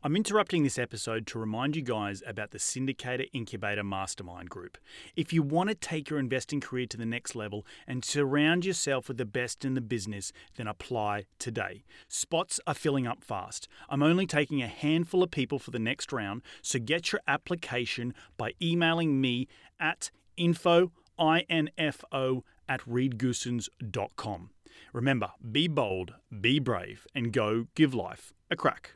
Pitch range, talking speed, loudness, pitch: 115-155 Hz, 160 wpm, -31 LUFS, 130 Hz